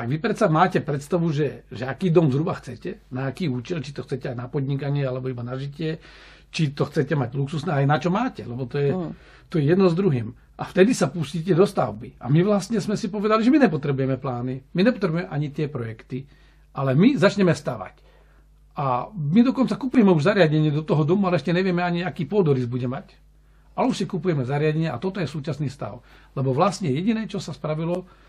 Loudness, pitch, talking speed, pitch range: -23 LUFS, 155 Hz, 210 wpm, 135-185 Hz